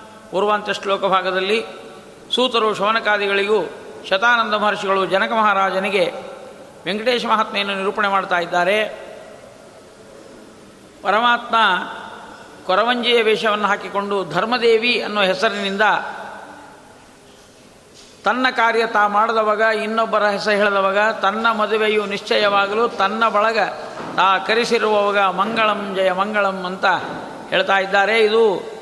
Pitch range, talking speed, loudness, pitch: 195-225 Hz, 85 wpm, -17 LUFS, 210 Hz